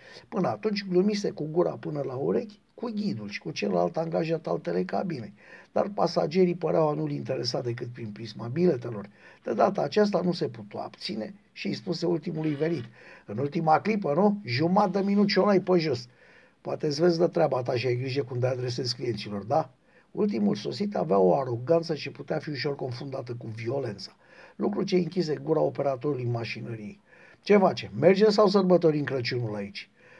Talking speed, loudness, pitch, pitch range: 175 wpm, -27 LUFS, 155 Hz, 125-180 Hz